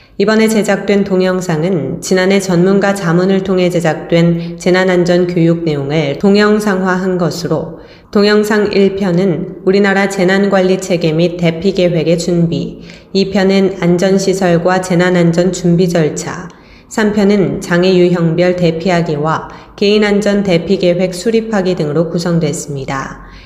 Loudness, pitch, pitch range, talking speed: -12 LUFS, 180 Hz, 170-195 Hz, 285 characters per minute